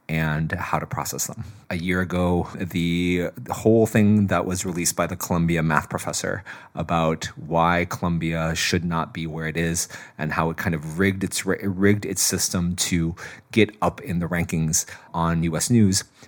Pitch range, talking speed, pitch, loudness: 80-95 Hz, 175 wpm, 85 Hz, -23 LUFS